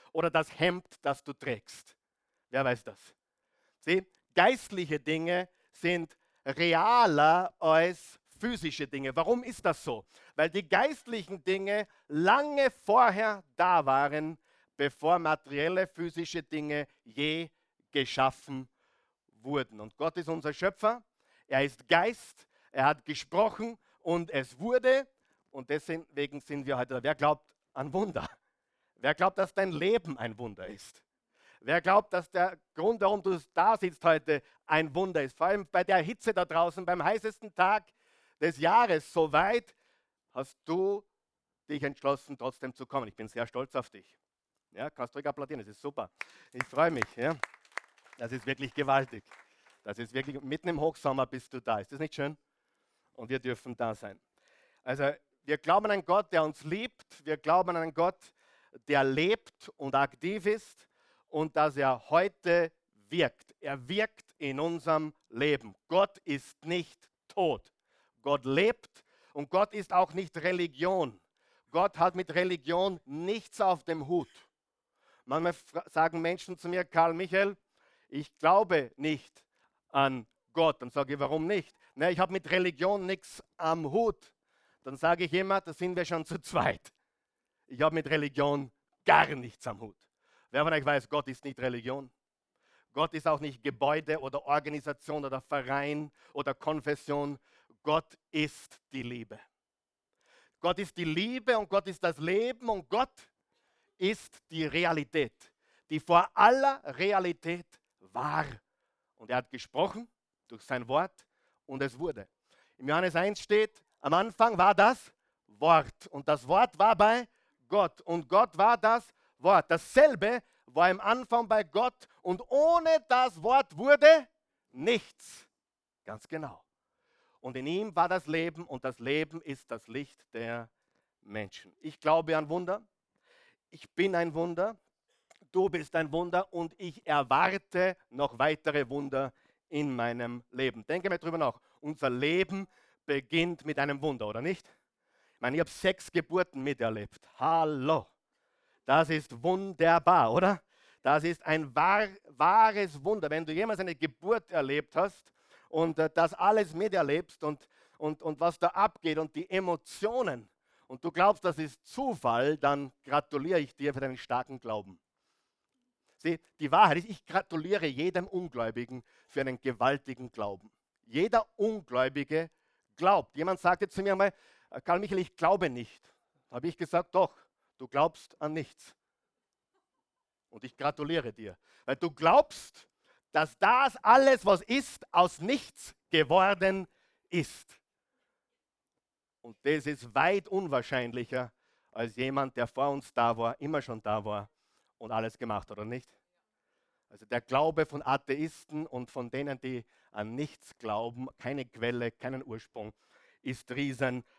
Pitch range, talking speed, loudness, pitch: 140-185 Hz, 150 wpm, -30 LUFS, 160 Hz